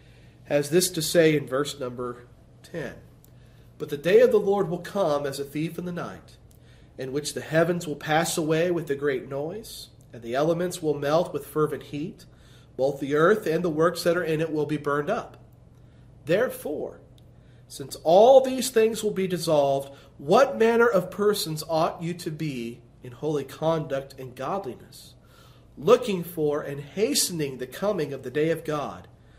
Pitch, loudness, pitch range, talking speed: 150 Hz, -25 LUFS, 135-175 Hz, 180 wpm